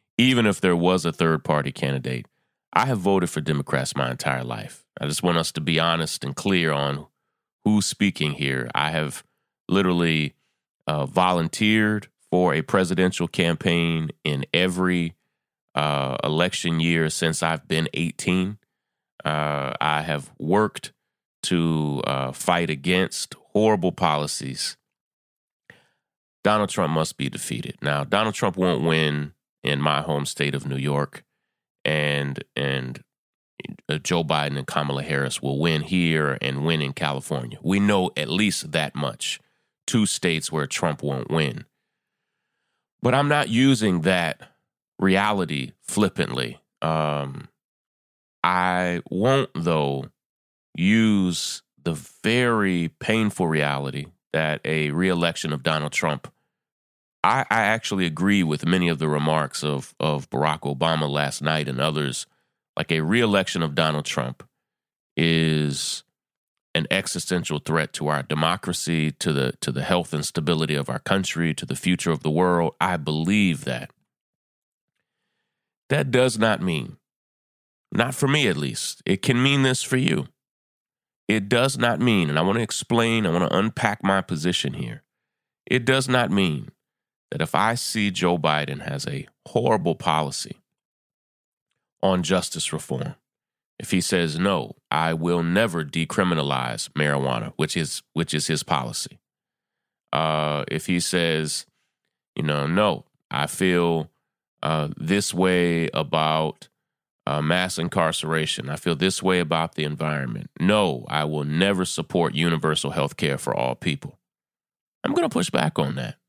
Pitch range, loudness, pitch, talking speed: 75-90 Hz, -23 LUFS, 80 Hz, 140 wpm